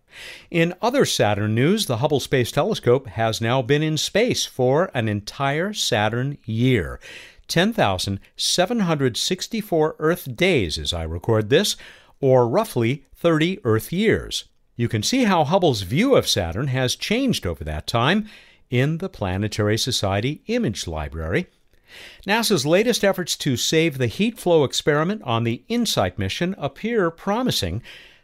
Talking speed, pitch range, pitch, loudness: 135 wpm, 110-180 Hz, 135 Hz, -21 LUFS